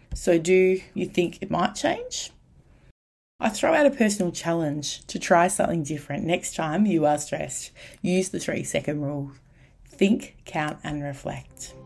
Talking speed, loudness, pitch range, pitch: 155 wpm, -25 LUFS, 145-190 Hz, 170 Hz